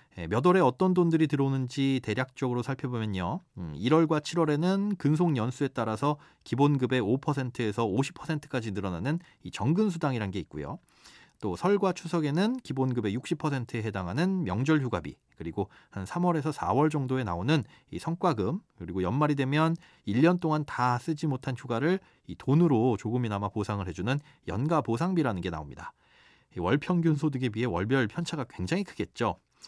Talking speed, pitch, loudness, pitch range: 330 characters per minute, 140 Hz, -29 LUFS, 120-160 Hz